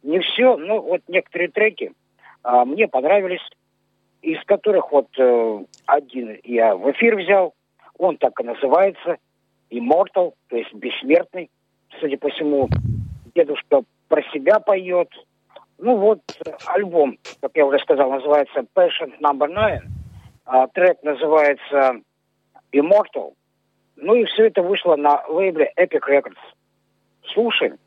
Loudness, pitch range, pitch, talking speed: -19 LUFS, 135-200 Hz, 165 Hz, 125 wpm